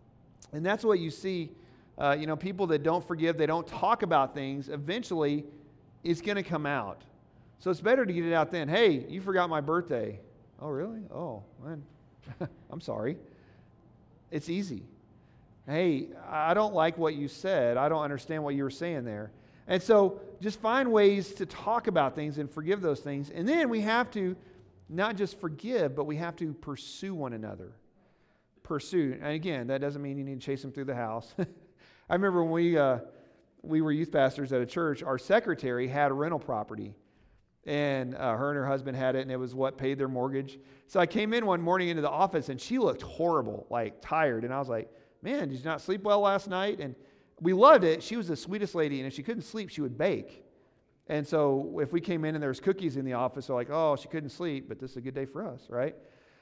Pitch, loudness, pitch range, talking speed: 150 Hz, -30 LUFS, 135-180 Hz, 220 wpm